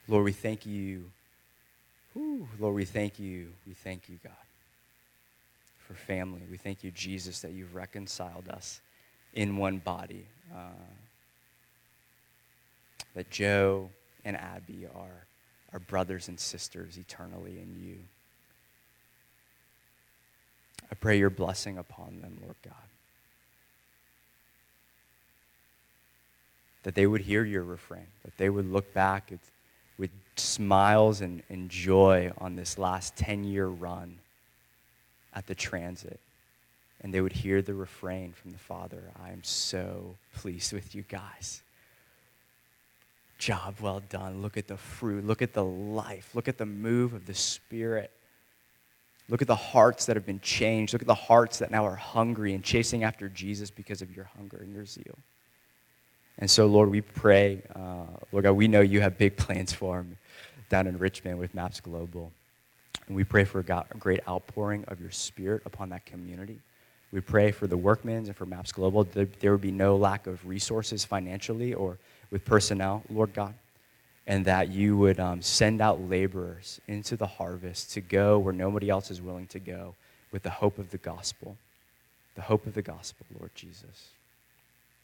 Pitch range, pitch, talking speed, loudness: 90-105 Hz, 95 Hz, 160 wpm, -29 LUFS